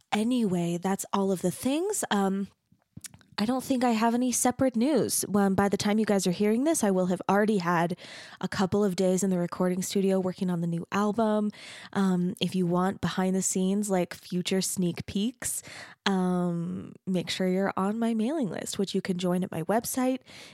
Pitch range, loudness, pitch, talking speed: 185-215 Hz, -28 LUFS, 195 Hz, 200 wpm